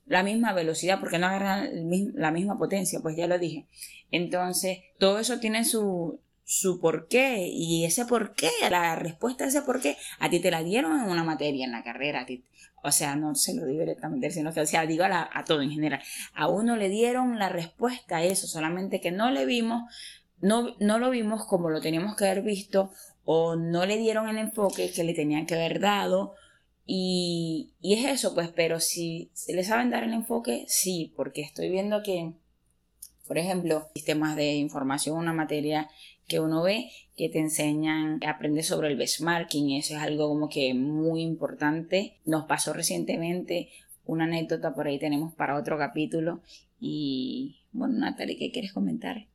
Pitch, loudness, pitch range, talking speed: 170 Hz, -28 LUFS, 155-205 Hz, 185 wpm